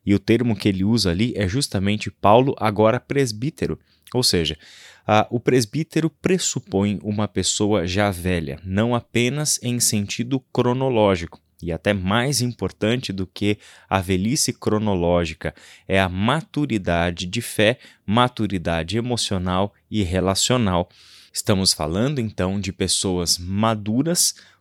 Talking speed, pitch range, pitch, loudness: 125 wpm, 95-120 Hz, 105 Hz, -21 LUFS